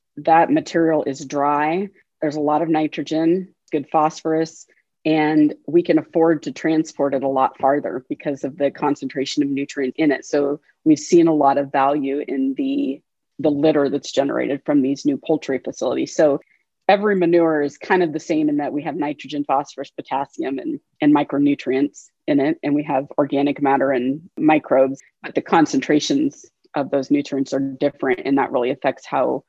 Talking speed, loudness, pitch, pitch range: 175 wpm, -20 LUFS, 150 Hz, 140-170 Hz